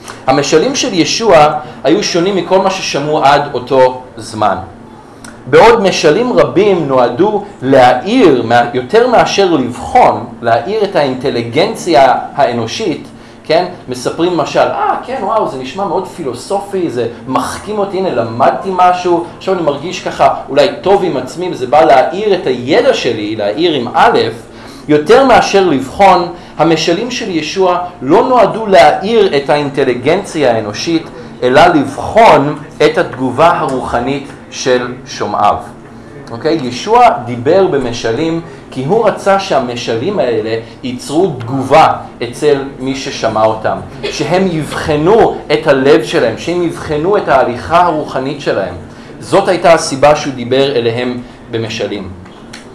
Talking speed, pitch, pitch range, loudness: 125 wpm, 145 Hz, 125-180 Hz, -11 LUFS